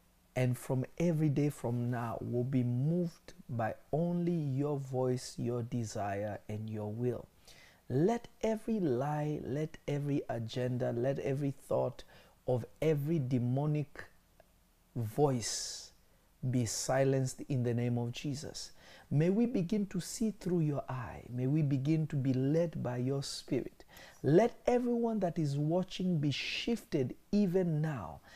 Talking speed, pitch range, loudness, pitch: 135 wpm, 125-165 Hz, -34 LUFS, 140 Hz